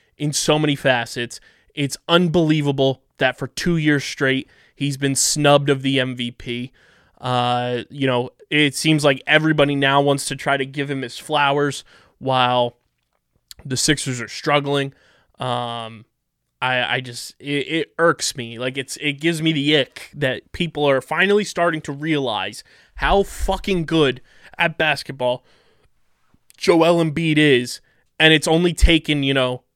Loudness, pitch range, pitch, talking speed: -19 LUFS, 125-155 Hz, 140 Hz, 150 wpm